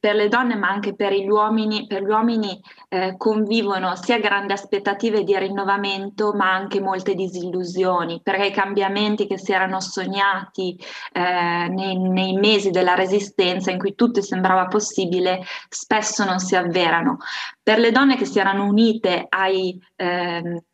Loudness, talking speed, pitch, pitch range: -20 LUFS, 155 wpm, 195 Hz, 185-210 Hz